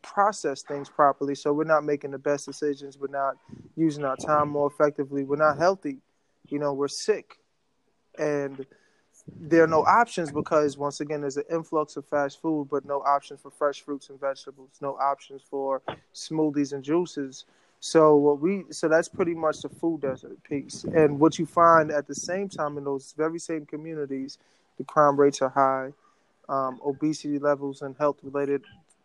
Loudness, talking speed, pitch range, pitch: -26 LUFS, 180 wpm, 140-155 Hz, 145 Hz